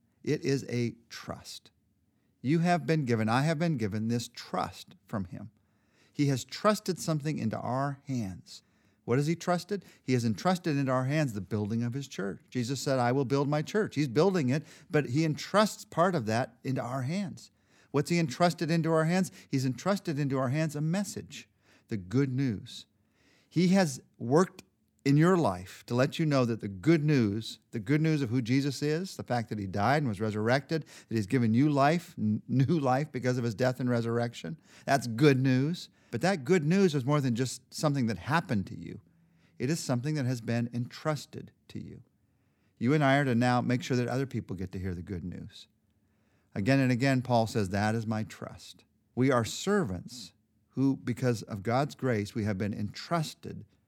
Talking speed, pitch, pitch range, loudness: 200 wpm, 130 Hz, 110-155 Hz, -30 LUFS